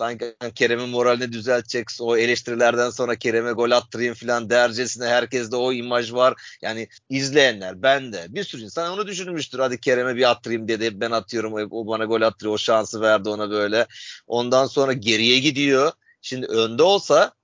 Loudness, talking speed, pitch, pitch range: -21 LUFS, 170 wpm, 120 Hz, 115-130 Hz